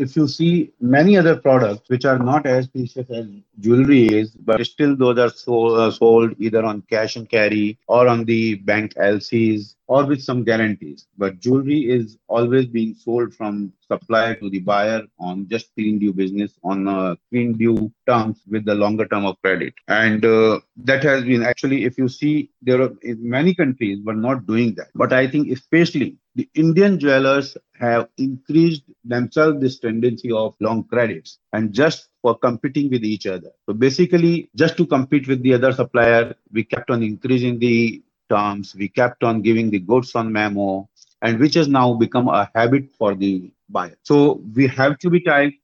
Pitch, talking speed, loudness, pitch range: 120 Hz, 185 wpm, -18 LUFS, 110-135 Hz